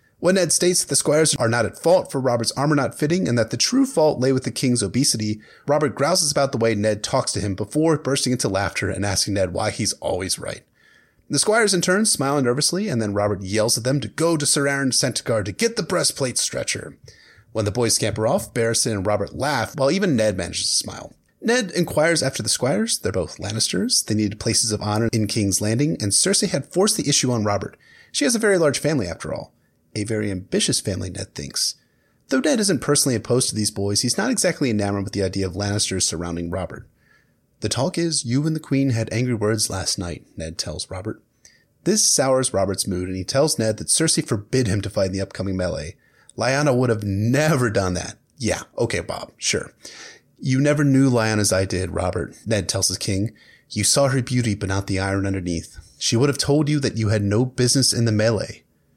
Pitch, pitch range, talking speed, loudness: 115 Hz, 100-145 Hz, 220 wpm, -21 LUFS